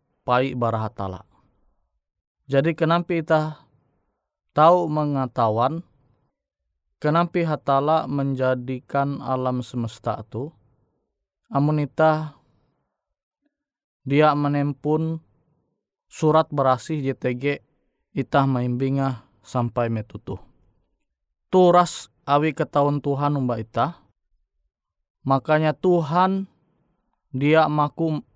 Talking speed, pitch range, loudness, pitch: 70 wpm, 120-155 Hz, -22 LUFS, 140 Hz